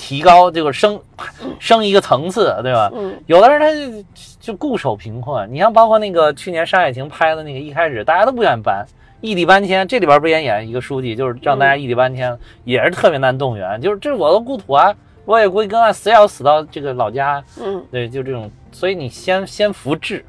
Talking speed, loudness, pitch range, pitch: 330 characters per minute, -15 LUFS, 130-205 Hz, 160 Hz